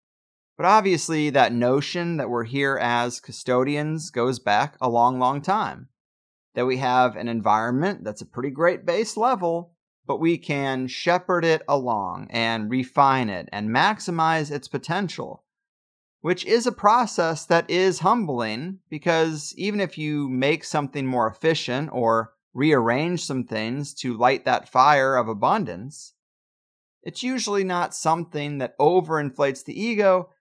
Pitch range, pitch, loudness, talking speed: 125-175 Hz, 145 Hz, -23 LUFS, 140 wpm